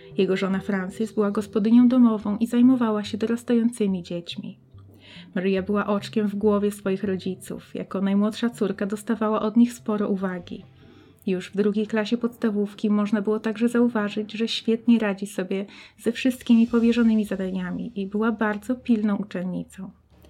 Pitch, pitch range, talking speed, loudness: 210 Hz, 195-230 Hz, 140 wpm, -24 LUFS